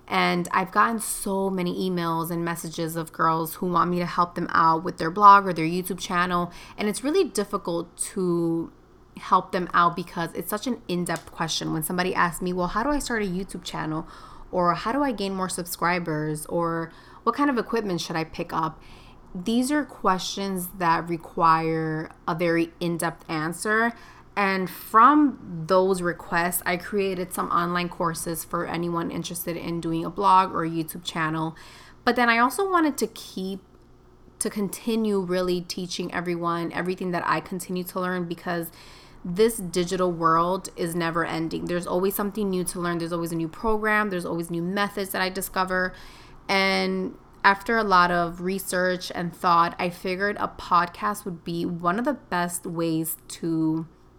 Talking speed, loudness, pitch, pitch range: 175 wpm, -25 LUFS, 180 Hz, 170-195 Hz